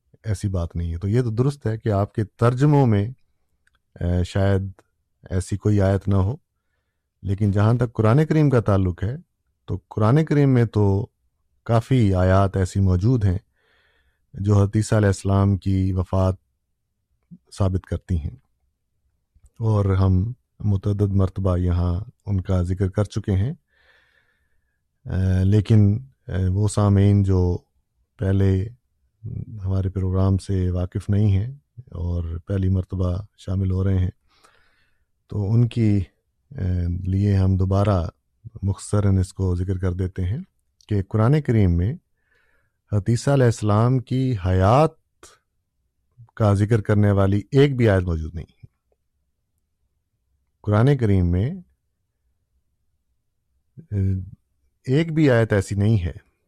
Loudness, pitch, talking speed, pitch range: -21 LUFS, 100 Hz, 125 wpm, 95-110 Hz